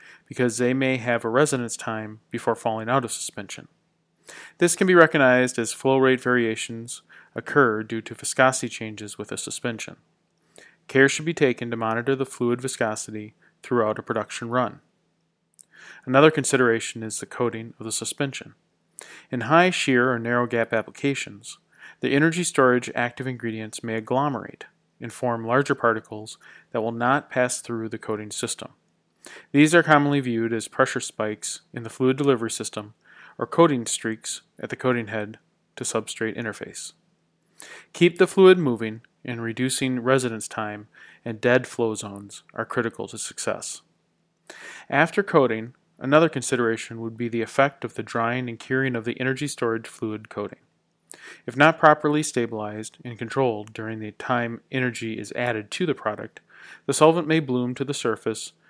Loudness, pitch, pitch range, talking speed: -23 LUFS, 120 Hz, 110-135 Hz, 155 wpm